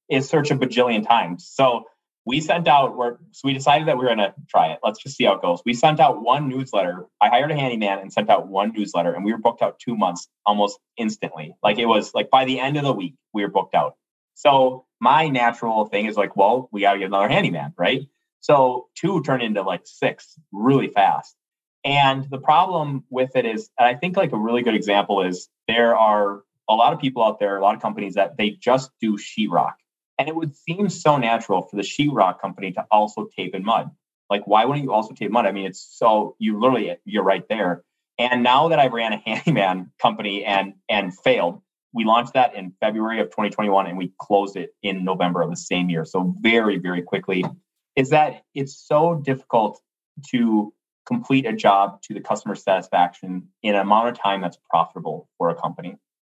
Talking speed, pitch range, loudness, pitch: 215 wpm, 100-135 Hz, -21 LUFS, 115 Hz